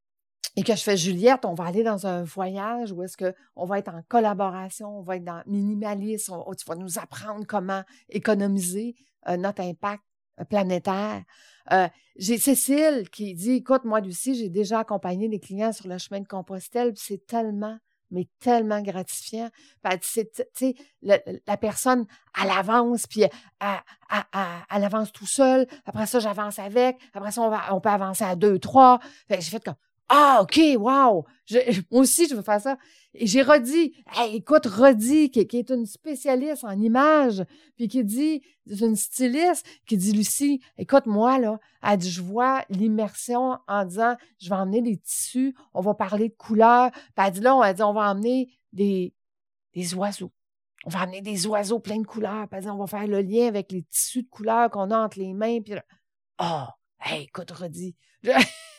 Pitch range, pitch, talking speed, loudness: 195-250 Hz, 215 Hz, 195 wpm, -23 LUFS